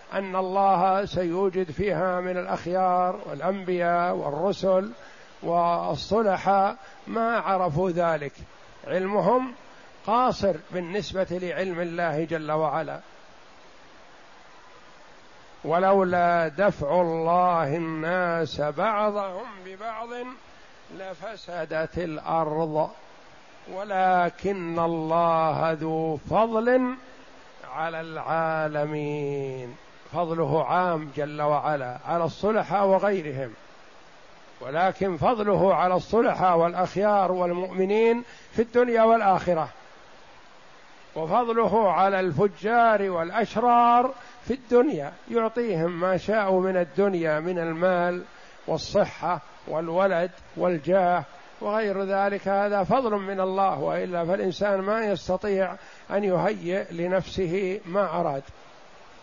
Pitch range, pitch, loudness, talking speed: 170-200 Hz, 185 Hz, -25 LUFS, 80 wpm